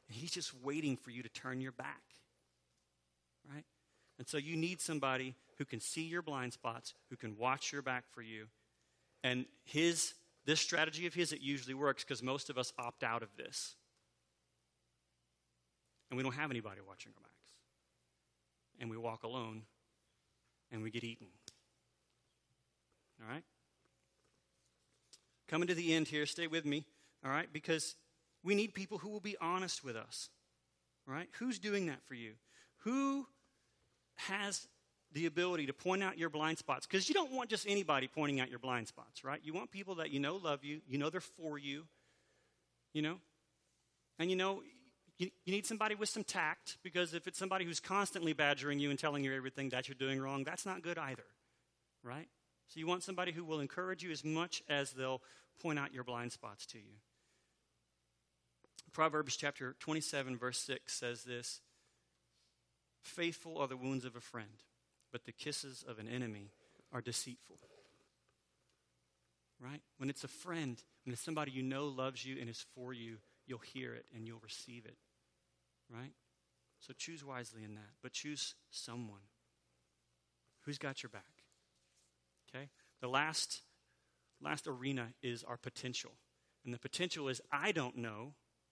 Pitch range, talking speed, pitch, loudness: 110-160 Hz, 170 wpm, 130 Hz, -41 LUFS